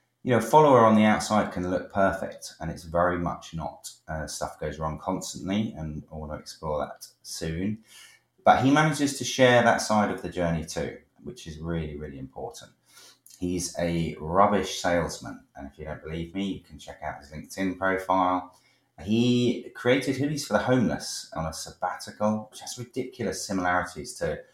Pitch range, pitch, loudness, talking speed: 85-115 Hz, 95 Hz, -26 LUFS, 180 wpm